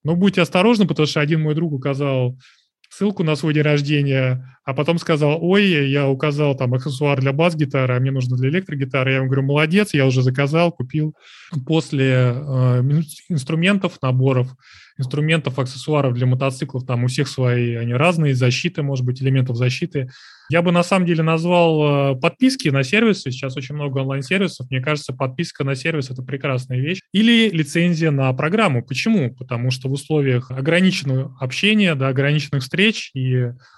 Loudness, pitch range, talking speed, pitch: -19 LUFS, 130-165 Hz, 165 wpm, 145 Hz